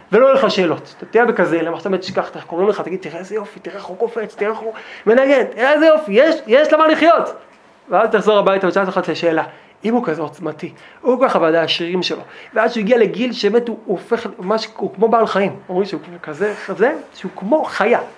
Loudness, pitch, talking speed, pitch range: -16 LUFS, 205 Hz, 220 wpm, 180-230 Hz